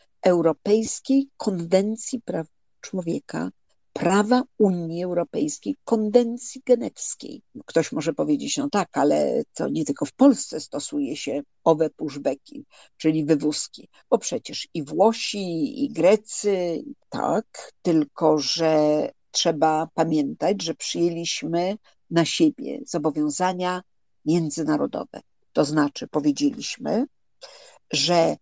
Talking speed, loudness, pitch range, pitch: 100 wpm, -24 LUFS, 160-250 Hz, 180 Hz